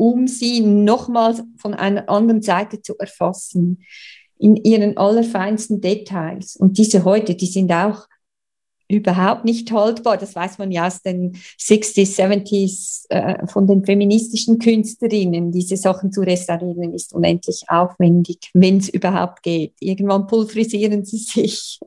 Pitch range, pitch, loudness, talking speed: 185-215 Hz, 200 Hz, -17 LUFS, 135 wpm